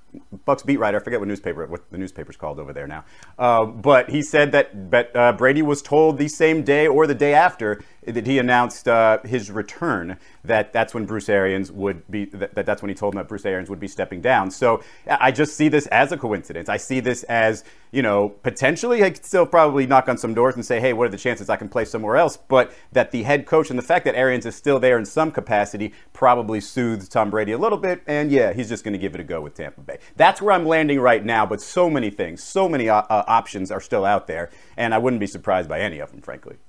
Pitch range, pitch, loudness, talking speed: 105-145 Hz, 120 Hz, -20 LUFS, 255 wpm